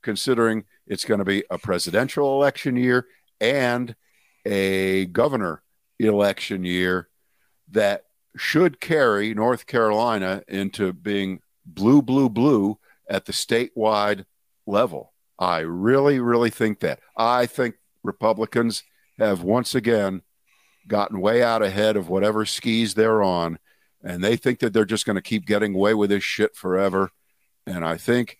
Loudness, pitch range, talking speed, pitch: -22 LUFS, 95-120 Hz, 140 wpm, 110 Hz